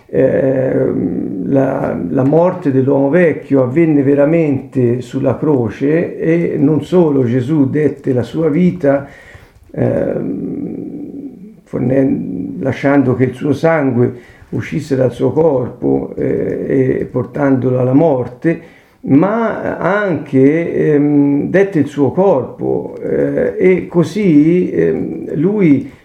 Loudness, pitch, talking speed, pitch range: -14 LUFS, 140 Hz, 105 wpm, 130-170 Hz